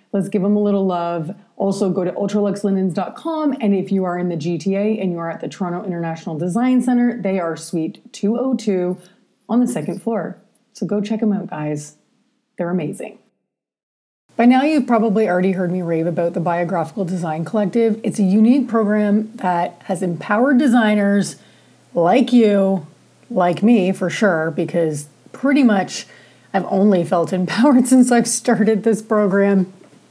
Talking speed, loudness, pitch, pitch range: 165 wpm, -18 LUFS, 200 Hz, 180-225 Hz